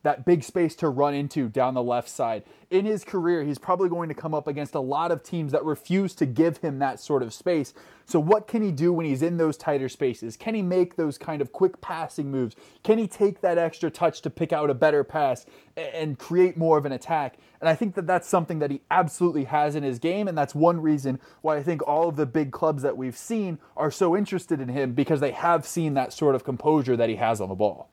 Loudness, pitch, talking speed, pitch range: -25 LUFS, 160 Hz, 255 wpm, 145-175 Hz